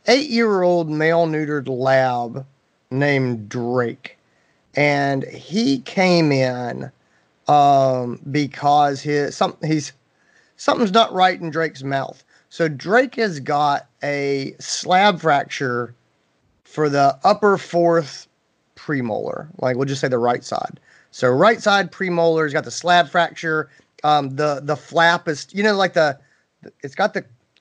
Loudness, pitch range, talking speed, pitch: -19 LUFS, 135-175 Hz, 135 wpm, 150 Hz